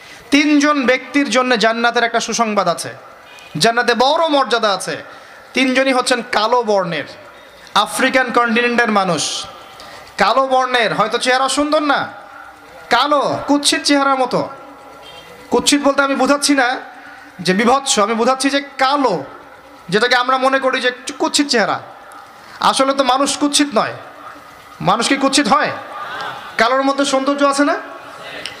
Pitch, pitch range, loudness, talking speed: 260 Hz, 235-280 Hz, -15 LUFS, 125 wpm